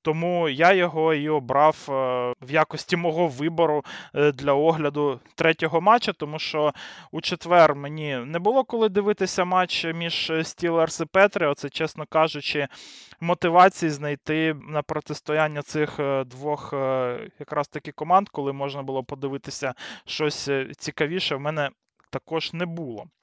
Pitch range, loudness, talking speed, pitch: 145-170 Hz, -24 LUFS, 125 wpm, 155 Hz